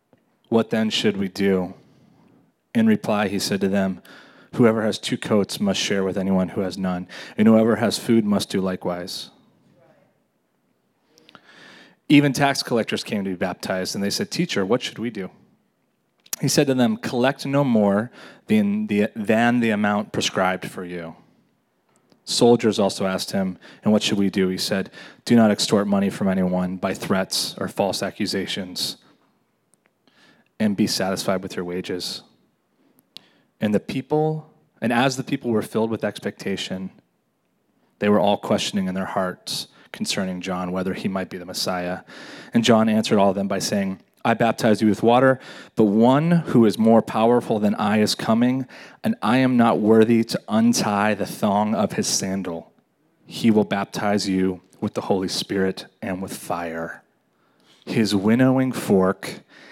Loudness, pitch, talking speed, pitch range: -21 LUFS, 105 Hz, 165 wpm, 95-120 Hz